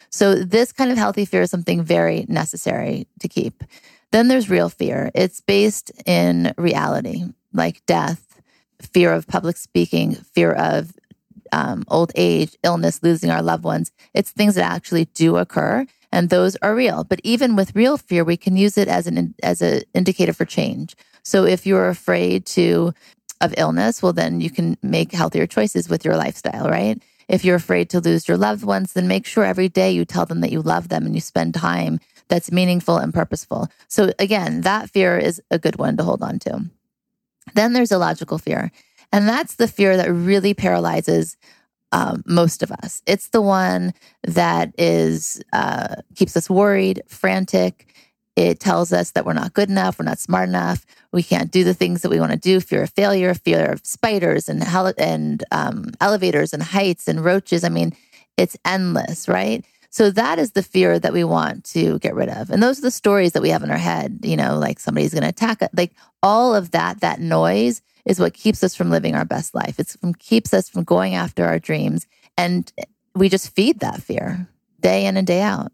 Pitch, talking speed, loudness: 175 Hz, 200 wpm, -19 LUFS